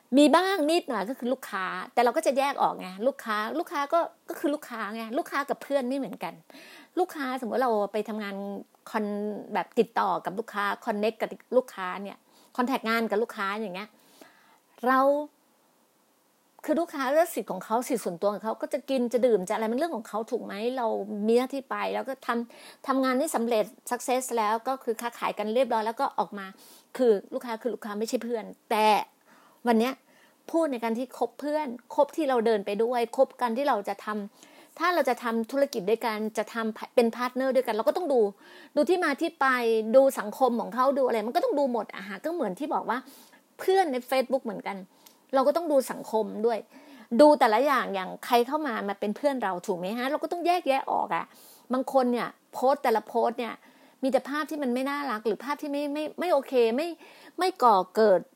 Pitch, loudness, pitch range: 250 Hz, -27 LUFS, 225-290 Hz